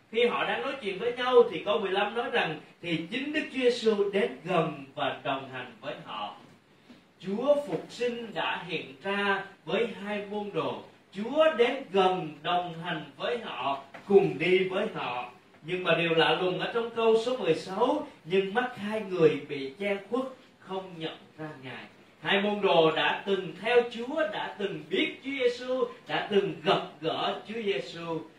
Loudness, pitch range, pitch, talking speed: -29 LUFS, 165-235 Hz, 195 Hz, 180 wpm